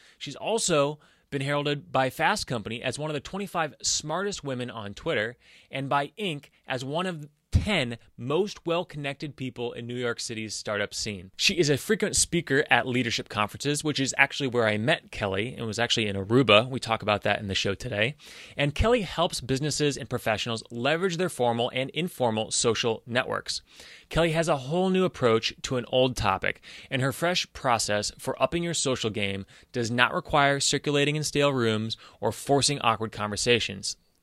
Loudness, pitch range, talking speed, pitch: -26 LUFS, 115-150 Hz, 180 wpm, 130 Hz